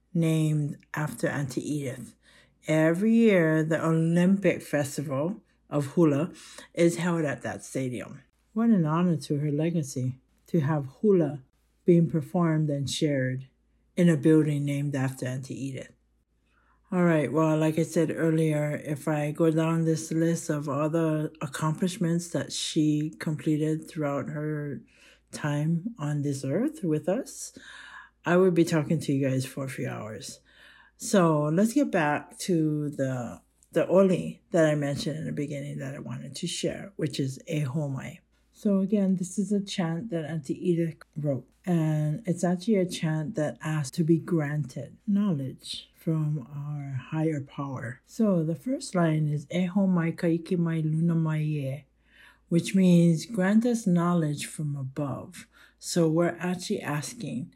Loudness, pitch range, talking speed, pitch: -27 LUFS, 145-170 Hz, 150 wpm, 160 Hz